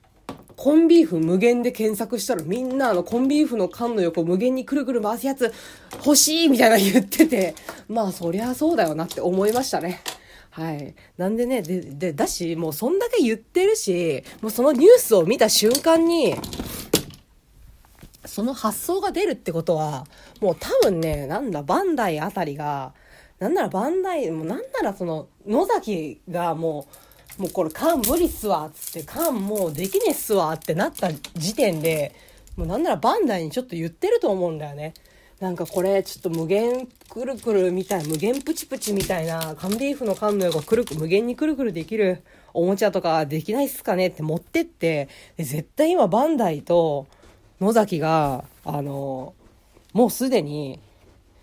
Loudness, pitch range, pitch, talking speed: -22 LUFS, 165-255 Hz, 200 Hz, 350 characters per minute